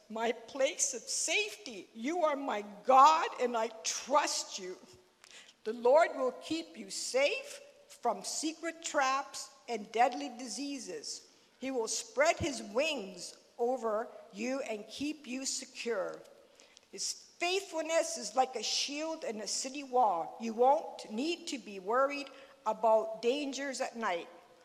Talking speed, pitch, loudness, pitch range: 135 wpm, 265 Hz, -33 LUFS, 230-305 Hz